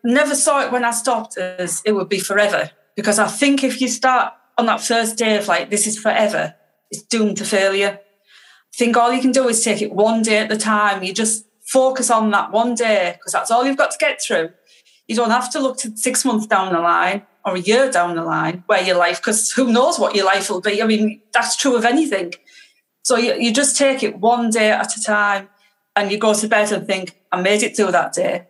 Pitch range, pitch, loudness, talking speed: 200-245 Hz, 220 Hz, -17 LUFS, 245 wpm